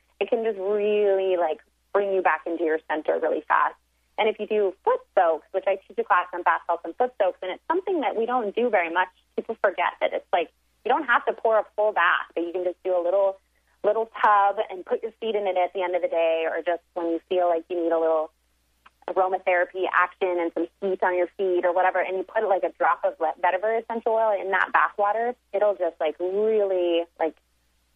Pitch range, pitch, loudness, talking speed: 170-210 Hz, 185 Hz, -24 LUFS, 240 wpm